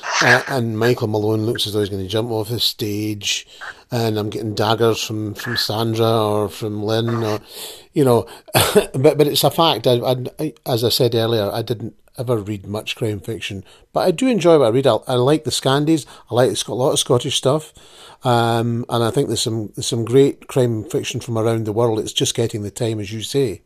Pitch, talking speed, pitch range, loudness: 115 Hz, 235 wpm, 110-130 Hz, -19 LUFS